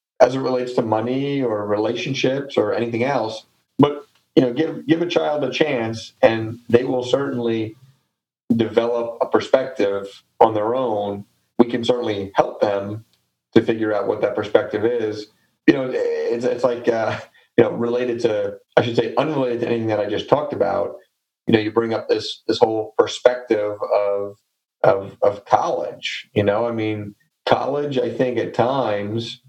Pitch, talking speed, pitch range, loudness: 115 Hz, 170 wpm, 110-135 Hz, -20 LUFS